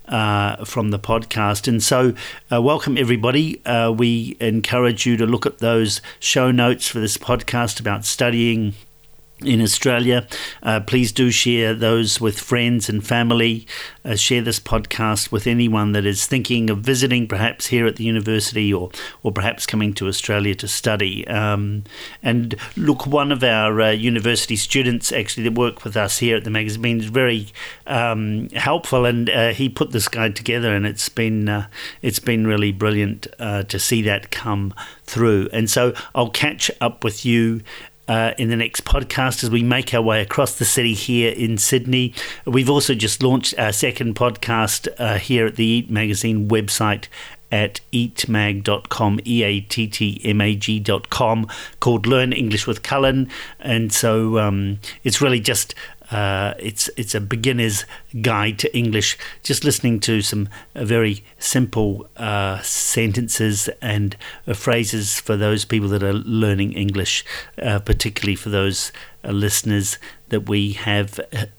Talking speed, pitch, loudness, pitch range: 165 wpm, 115 Hz, -19 LUFS, 105-120 Hz